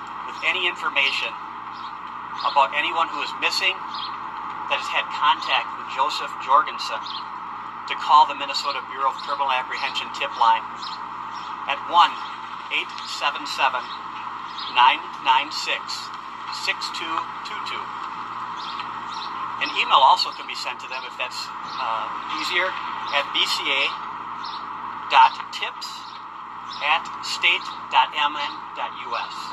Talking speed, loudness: 90 wpm, -23 LUFS